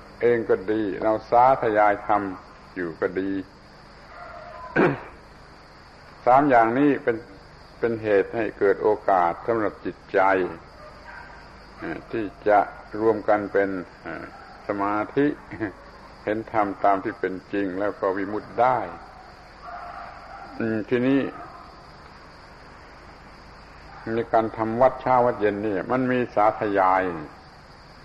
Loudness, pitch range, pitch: -23 LUFS, 95-115 Hz, 105 Hz